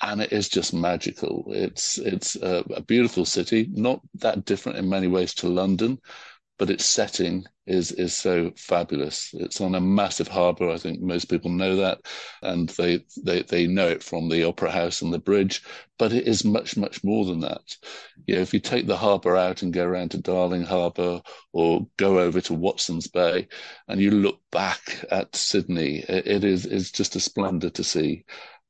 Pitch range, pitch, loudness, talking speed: 90-100 Hz, 90 Hz, -24 LUFS, 190 wpm